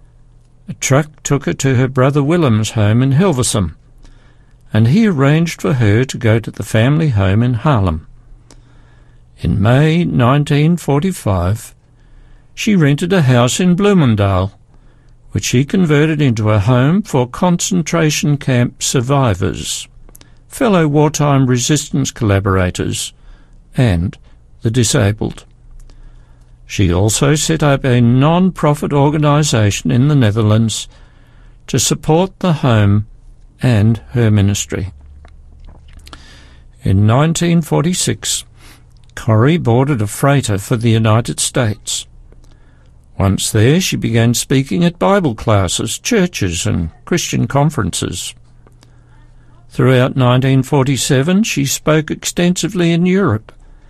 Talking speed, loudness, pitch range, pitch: 105 wpm, -14 LUFS, 105-150 Hz, 125 Hz